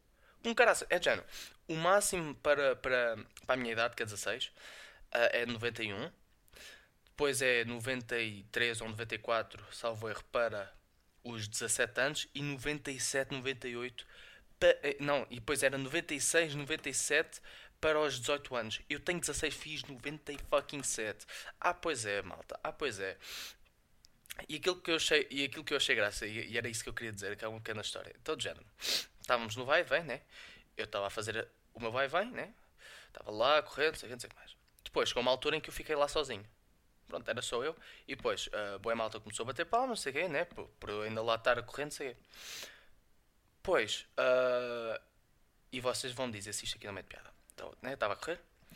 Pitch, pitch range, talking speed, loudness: 125 Hz, 110-145 Hz, 185 wpm, -35 LUFS